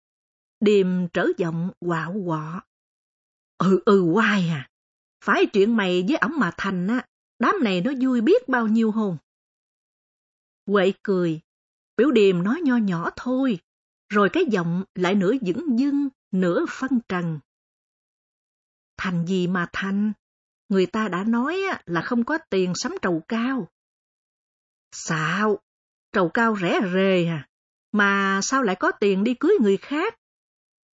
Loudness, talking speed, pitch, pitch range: -22 LUFS, 140 wpm, 195 Hz, 180-235 Hz